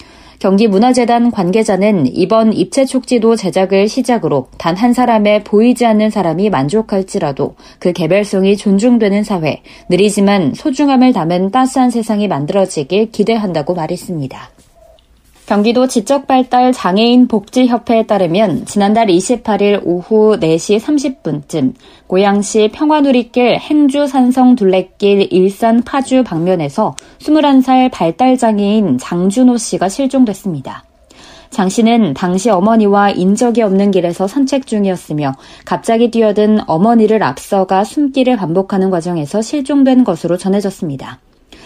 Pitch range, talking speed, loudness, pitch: 190-250 Hz, 305 characters per minute, -12 LUFS, 215 Hz